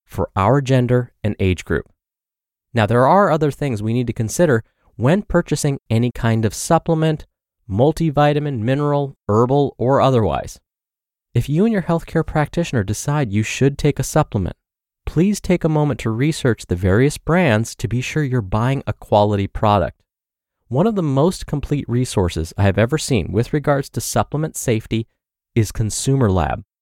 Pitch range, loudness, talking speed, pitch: 110-150 Hz, -18 LUFS, 165 wpm, 130 Hz